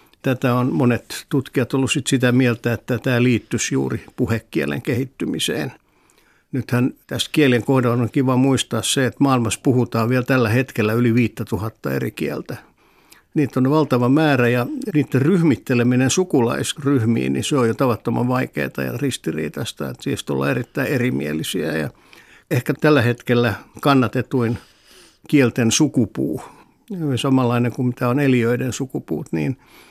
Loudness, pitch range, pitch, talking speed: -19 LUFS, 115-135 Hz, 125 Hz, 135 wpm